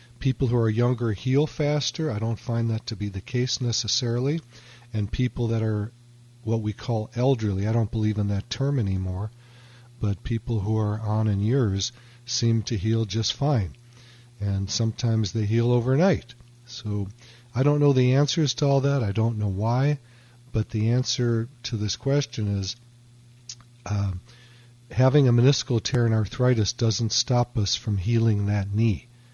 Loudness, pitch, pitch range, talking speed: -25 LUFS, 120 Hz, 110-125 Hz, 165 wpm